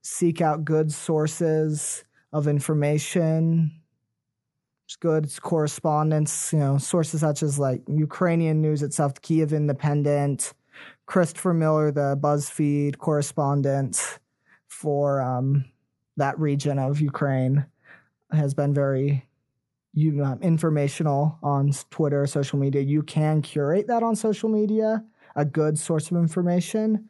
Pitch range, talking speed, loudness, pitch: 140-160 Hz, 115 wpm, -24 LUFS, 150 Hz